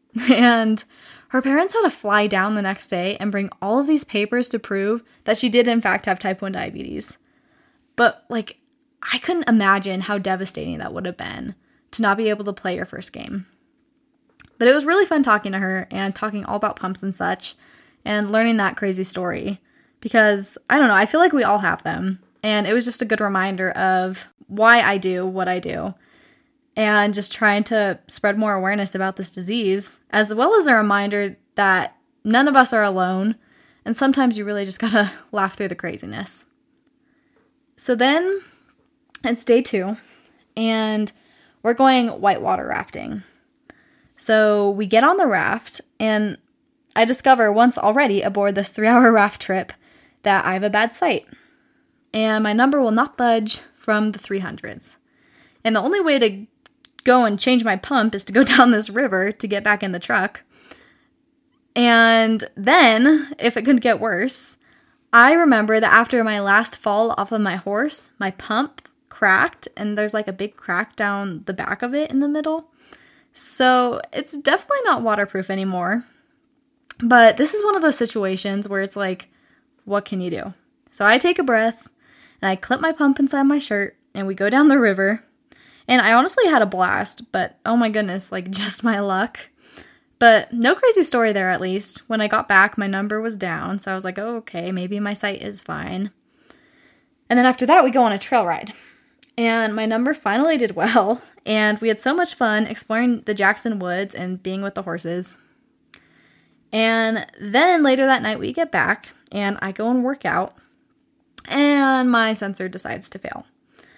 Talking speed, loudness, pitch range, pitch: 185 wpm, -19 LUFS, 200-275 Hz, 225 Hz